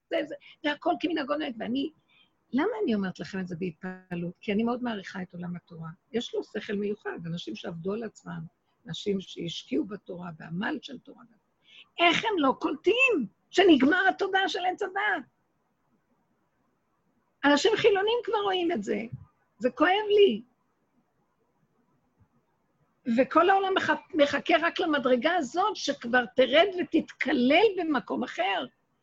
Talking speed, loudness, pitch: 130 wpm, -27 LUFS, 285 Hz